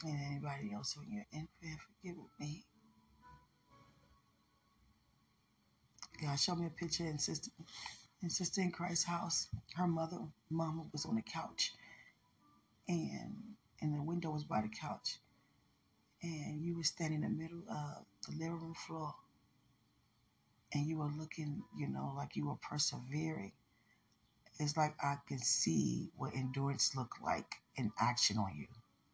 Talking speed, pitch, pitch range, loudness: 145 wpm, 150 Hz, 120-165 Hz, -40 LUFS